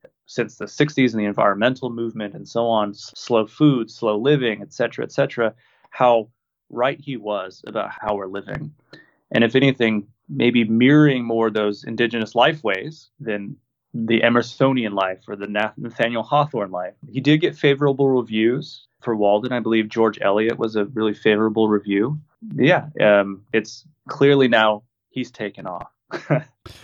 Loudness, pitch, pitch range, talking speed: -20 LUFS, 115 Hz, 105-130 Hz, 155 wpm